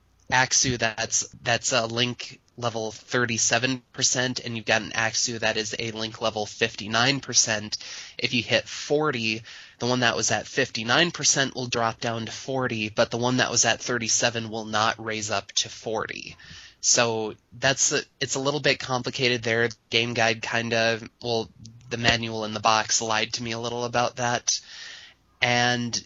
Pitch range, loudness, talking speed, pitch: 110-125 Hz, -24 LUFS, 170 wpm, 115 Hz